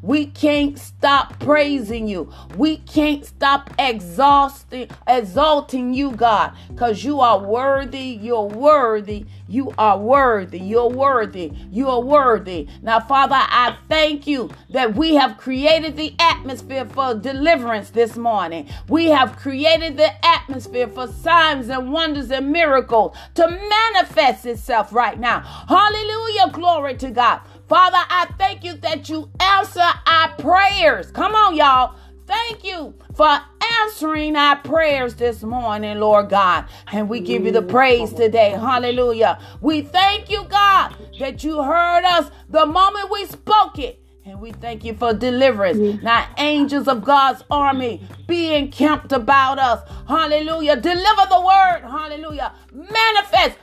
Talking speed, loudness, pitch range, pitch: 140 wpm, -17 LUFS, 245-330 Hz, 285 Hz